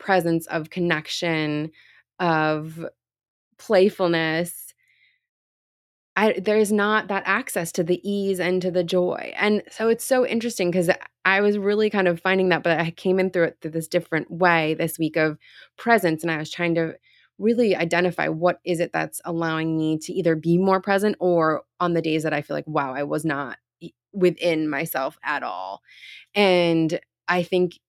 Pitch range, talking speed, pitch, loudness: 165-195 Hz, 175 wpm, 175 Hz, -22 LUFS